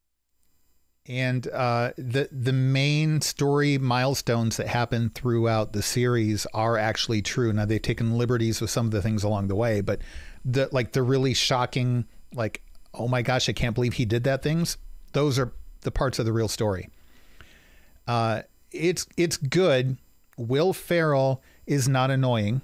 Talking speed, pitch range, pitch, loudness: 160 wpm, 110-135 Hz, 120 Hz, -25 LUFS